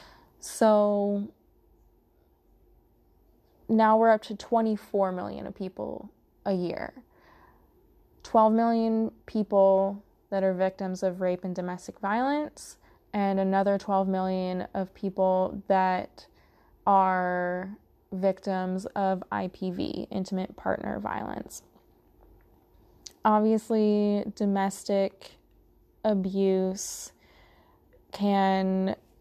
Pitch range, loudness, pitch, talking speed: 185-210 Hz, -27 LUFS, 195 Hz, 80 wpm